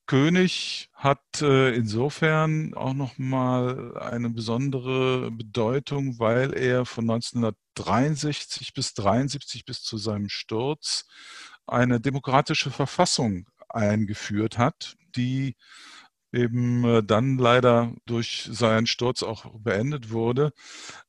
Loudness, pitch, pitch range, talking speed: -25 LUFS, 125 Hz, 115-135 Hz, 95 wpm